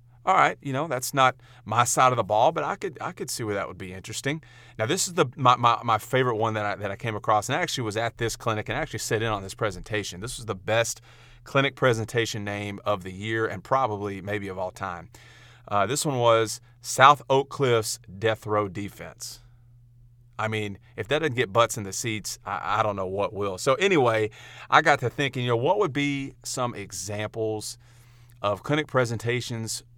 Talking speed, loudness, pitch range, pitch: 220 wpm, -25 LUFS, 105-125 Hz, 115 Hz